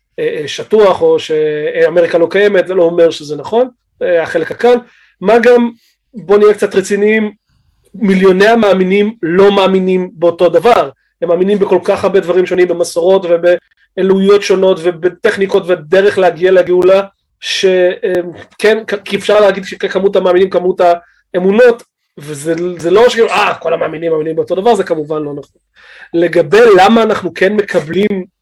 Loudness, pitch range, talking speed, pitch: -11 LUFS, 180-215 Hz, 135 wpm, 190 Hz